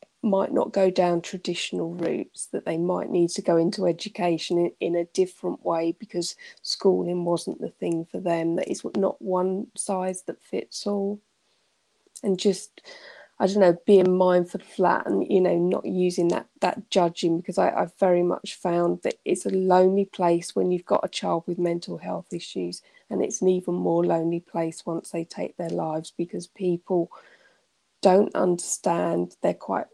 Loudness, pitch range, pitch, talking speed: -25 LUFS, 170-190 Hz, 180 Hz, 175 wpm